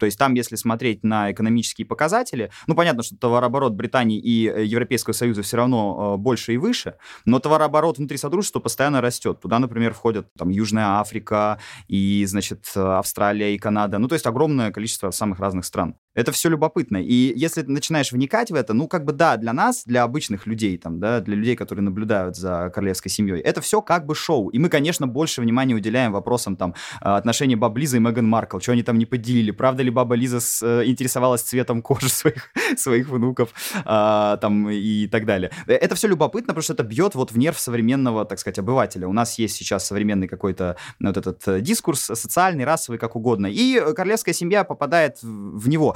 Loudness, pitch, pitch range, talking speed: -21 LUFS, 120 Hz, 105-135 Hz, 190 wpm